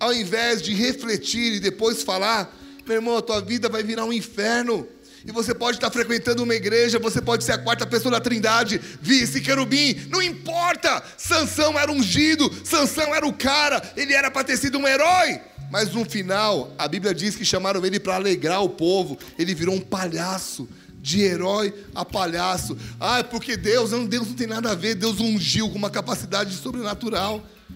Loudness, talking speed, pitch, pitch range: -22 LUFS, 185 wpm, 225 Hz, 200-245 Hz